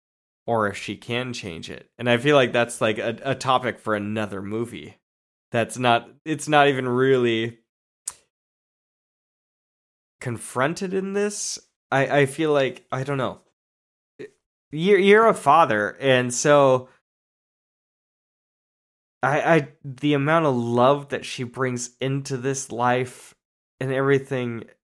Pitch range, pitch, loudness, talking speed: 115-140 Hz, 130 Hz, -22 LUFS, 130 wpm